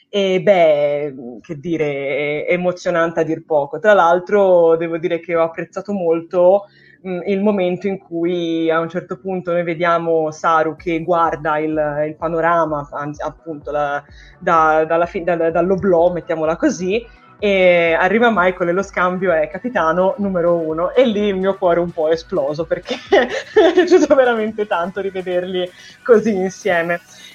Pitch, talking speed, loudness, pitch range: 175 Hz, 150 wpm, -17 LUFS, 165-190 Hz